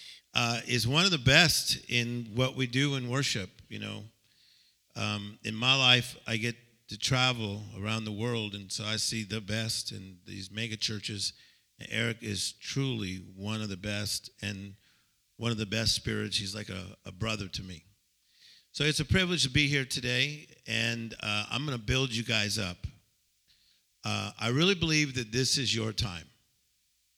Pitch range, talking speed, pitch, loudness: 105-125 Hz, 180 wpm, 110 Hz, -29 LUFS